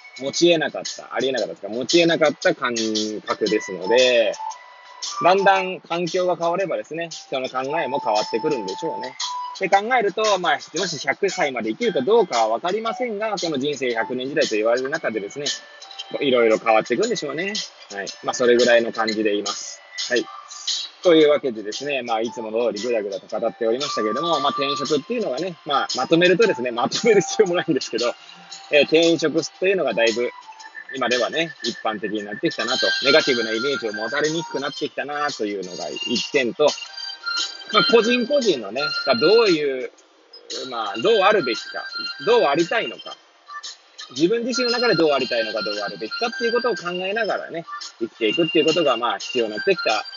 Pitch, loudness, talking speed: 170 Hz, -21 LUFS, 420 characters per minute